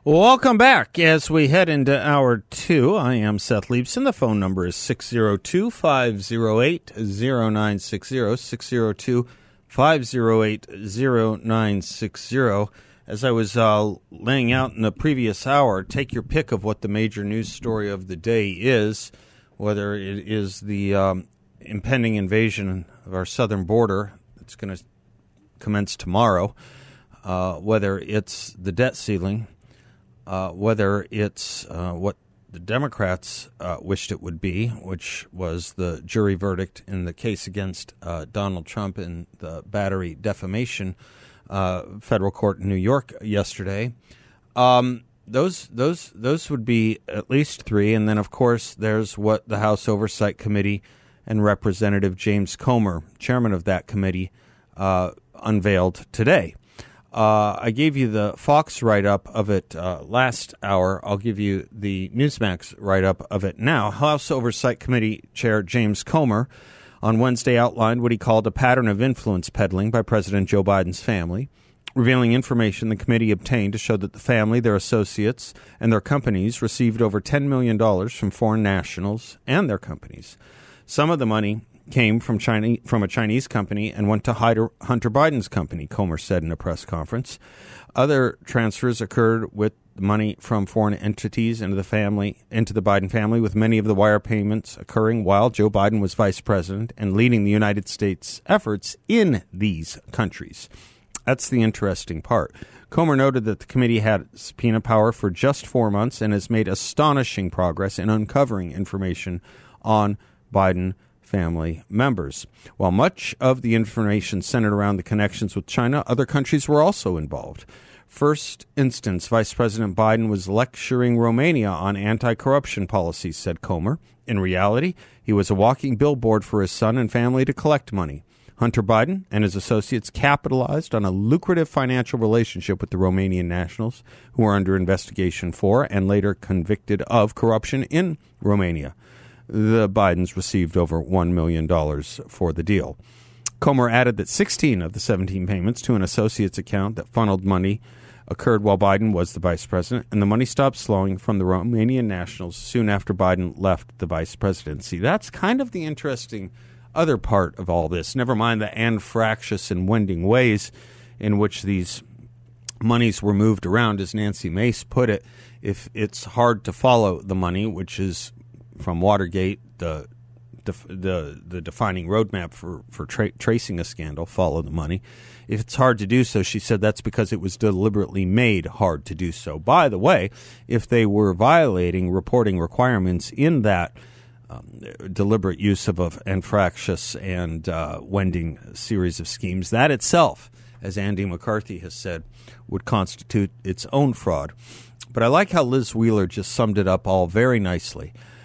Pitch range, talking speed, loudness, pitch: 95-120 Hz, 160 wpm, -22 LUFS, 110 Hz